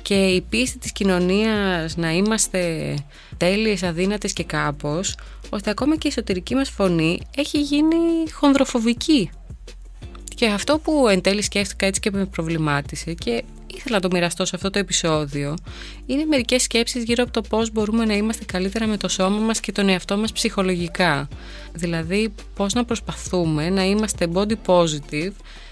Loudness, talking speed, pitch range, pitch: -21 LUFS, 160 wpm, 175-225 Hz, 195 Hz